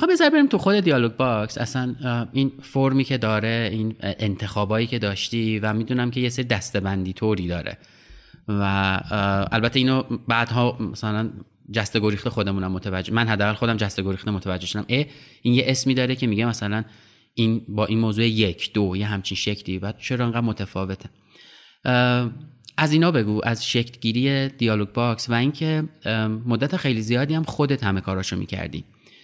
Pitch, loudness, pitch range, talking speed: 115 Hz, -23 LUFS, 105-125 Hz, 160 wpm